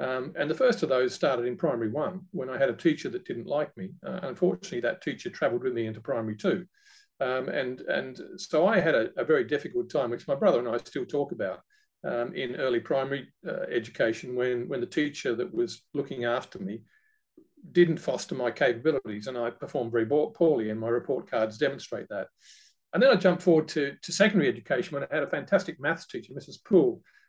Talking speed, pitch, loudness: 215 wpm, 175 Hz, -28 LUFS